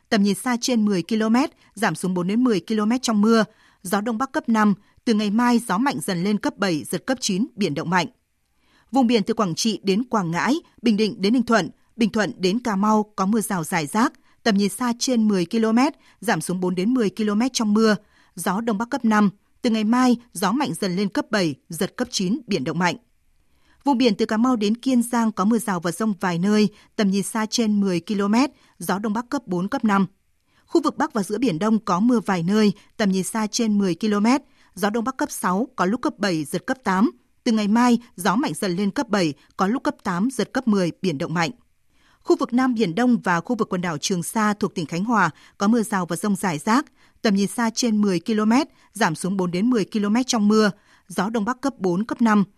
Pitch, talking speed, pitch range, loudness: 215 Hz, 240 wpm, 195-240 Hz, -22 LUFS